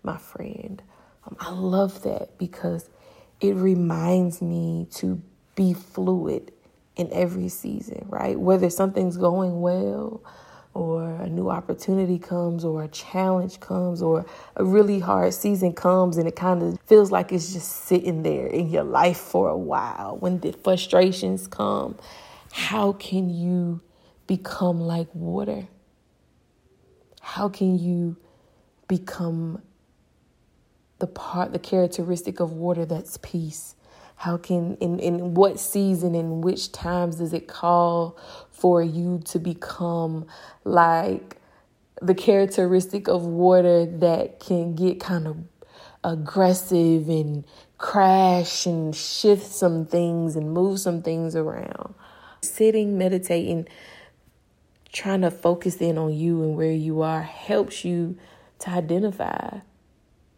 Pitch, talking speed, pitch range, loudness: 175 Hz, 125 wpm, 170-185 Hz, -23 LUFS